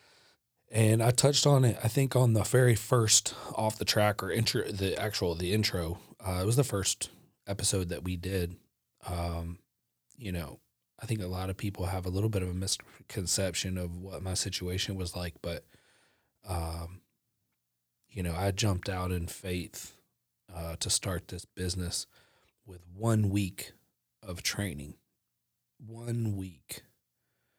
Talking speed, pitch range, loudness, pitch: 155 wpm, 85-105 Hz, -31 LUFS, 95 Hz